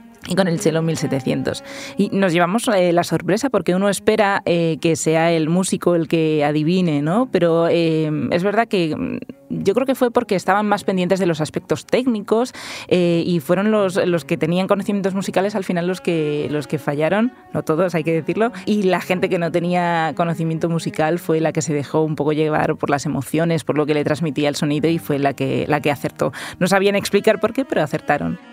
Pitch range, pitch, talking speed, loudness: 155-200 Hz, 175 Hz, 210 wpm, -19 LUFS